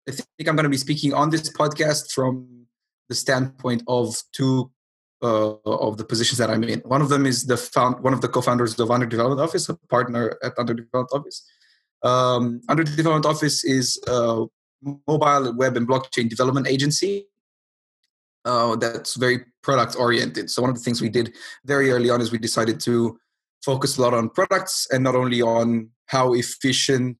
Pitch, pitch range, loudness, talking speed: 125 Hz, 120-140 Hz, -21 LUFS, 175 wpm